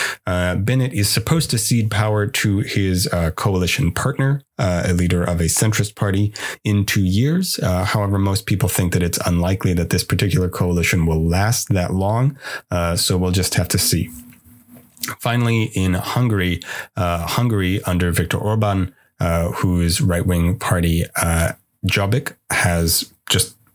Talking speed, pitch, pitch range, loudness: 155 wpm, 95 Hz, 90-110 Hz, -19 LUFS